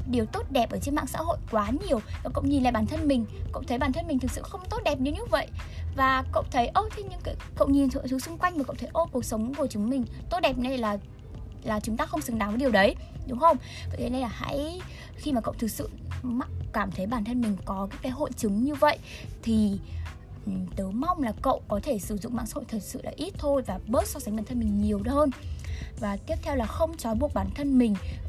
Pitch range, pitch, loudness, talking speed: 205-280 Hz, 240 Hz, -28 LUFS, 260 wpm